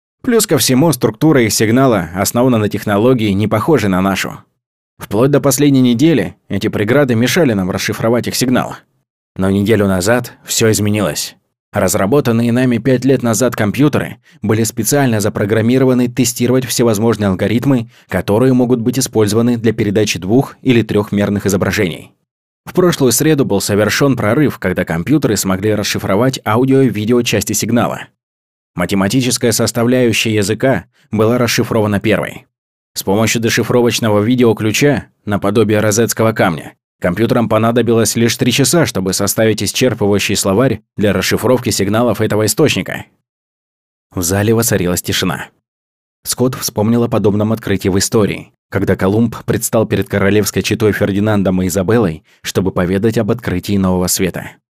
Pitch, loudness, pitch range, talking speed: 110 Hz, -13 LUFS, 100-125 Hz, 130 wpm